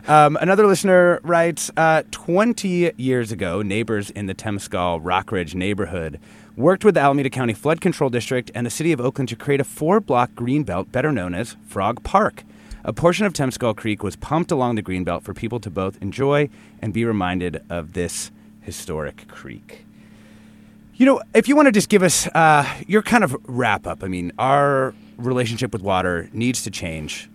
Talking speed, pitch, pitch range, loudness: 180 wpm, 120 Hz, 100-155 Hz, -20 LUFS